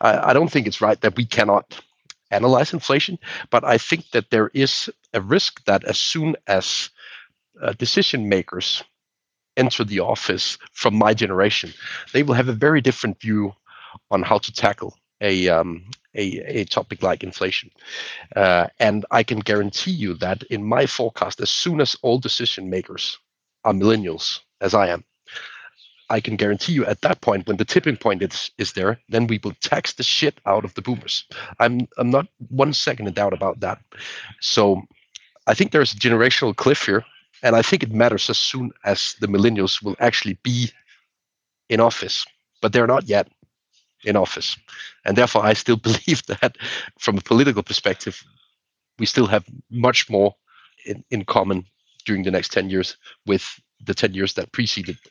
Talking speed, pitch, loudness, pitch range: 175 wpm, 115 Hz, -20 LUFS, 100-130 Hz